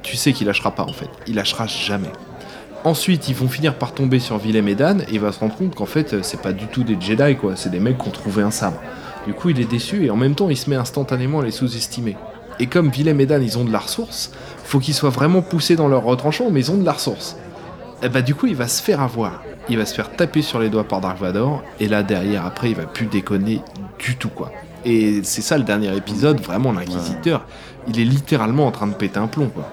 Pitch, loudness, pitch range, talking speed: 120 Hz, -19 LUFS, 105-145 Hz, 265 wpm